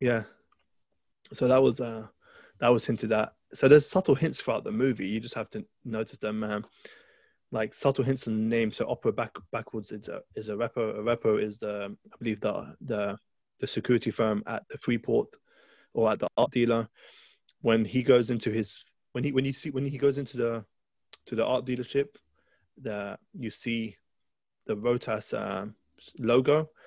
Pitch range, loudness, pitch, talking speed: 110-130 Hz, -29 LUFS, 115 Hz, 185 wpm